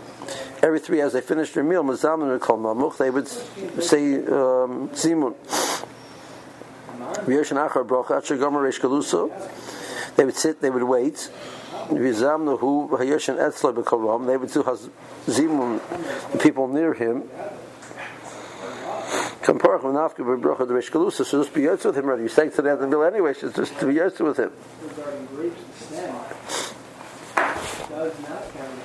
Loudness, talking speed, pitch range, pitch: -23 LUFS, 90 wpm, 130-155 Hz, 145 Hz